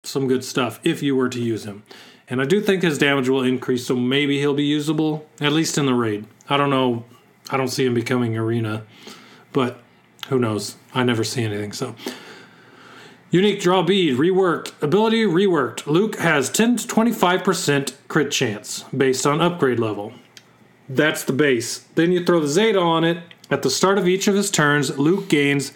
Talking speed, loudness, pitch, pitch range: 190 wpm, -20 LUFS, 140 Hz, 125-175 Hz